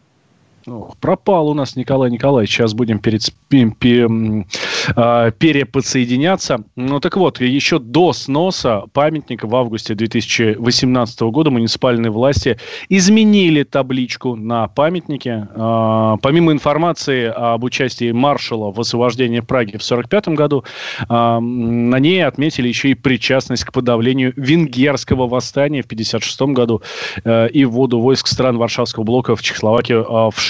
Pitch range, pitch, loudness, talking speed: 115-140 Hz, 125 Hz, -15 LUFS, 125 wpm